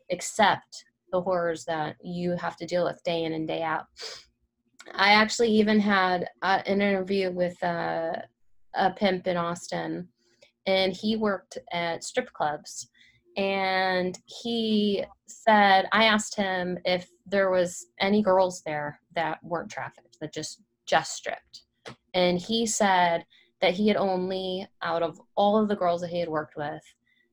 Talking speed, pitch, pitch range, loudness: 155 wpm, 185 Hz, 170-200 Hz, -26 LUFS